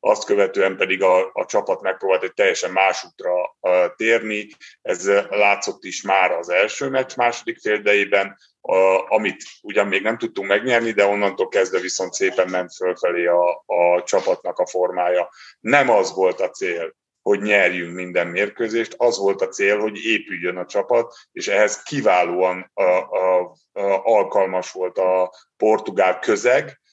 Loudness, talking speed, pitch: -19 LUFS, 155 wpm, 100 Hz